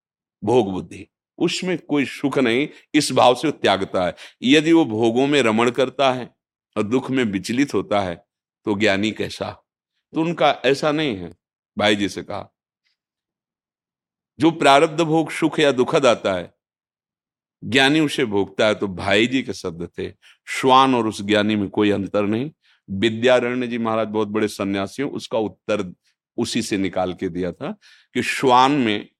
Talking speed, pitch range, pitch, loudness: 160 wpm, 100-140 Hz, 115 Hz, -20 LUFS